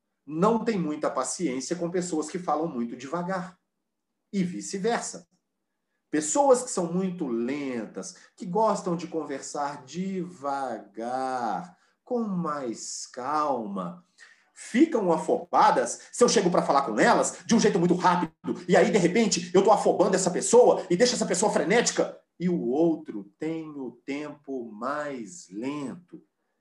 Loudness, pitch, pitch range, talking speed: -26 LUFS, 175 Hz, 145-210 Hz, 140 wpm